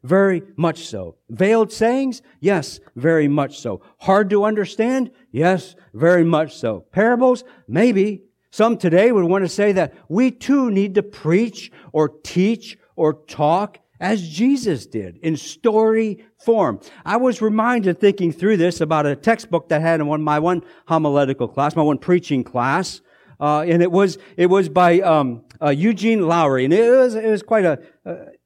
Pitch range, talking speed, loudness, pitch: 155-220 Hz, 170 wpm, -18 LUFS, 185 Hz